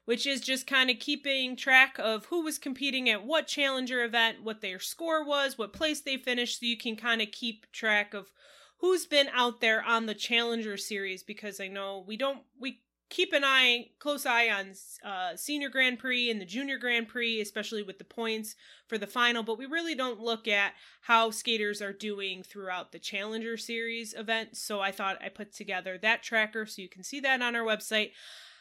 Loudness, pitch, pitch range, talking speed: -29 LUFS, 230 Hz, 210-265 Hz, 205 wpm